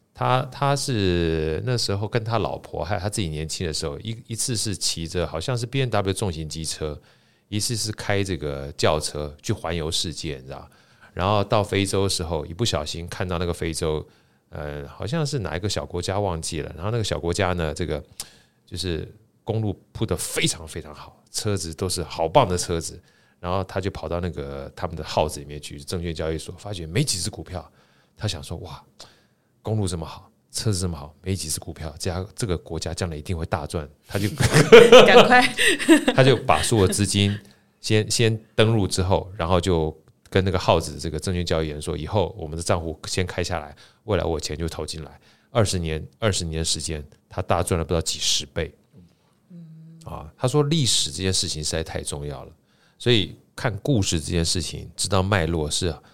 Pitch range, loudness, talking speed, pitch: 80-105 Hz, -23 LUFS, 290 characters per minute, 90 Hz